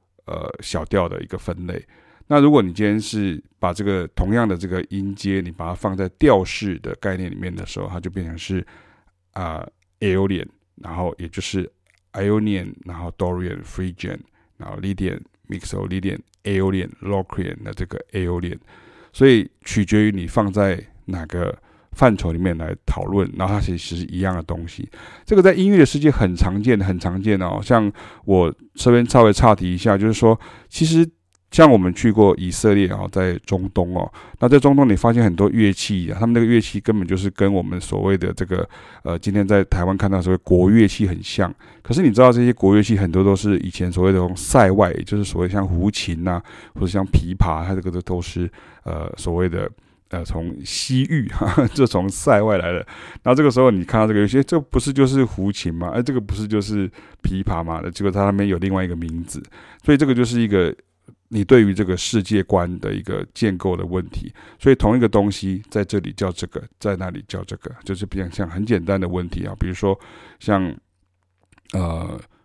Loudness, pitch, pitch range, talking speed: -19 LUFS, 95 Hz, 90-105 Hz, 330 characters per minute